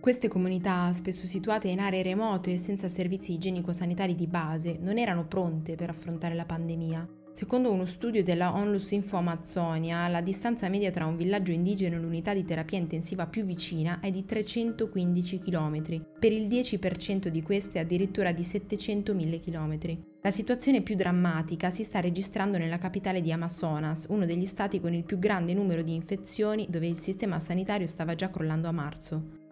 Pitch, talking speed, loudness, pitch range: 180 Hz, 170 wpm, -30 LUFS, 170-200 Hz